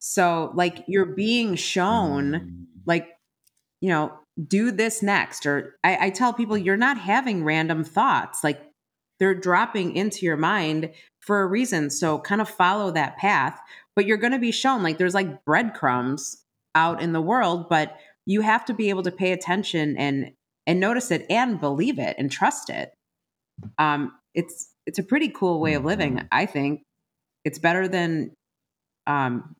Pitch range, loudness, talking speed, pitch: 155-200 Hz, -23 LUFS, 170 wpm, 175 Hz